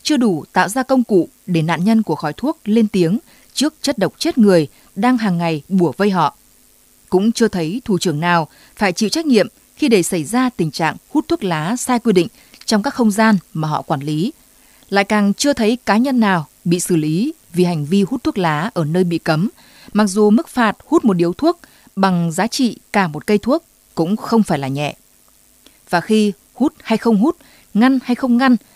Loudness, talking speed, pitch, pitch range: -17 LUFS, 220 wpm, 210 Hz, 175-250 Hz